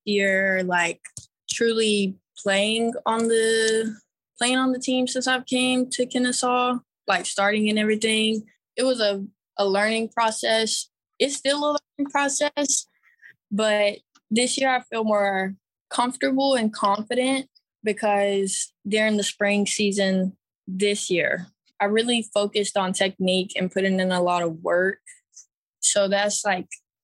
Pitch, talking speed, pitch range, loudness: 215 Hz, 135 wpm, 200-250 Hz, -23 LUFS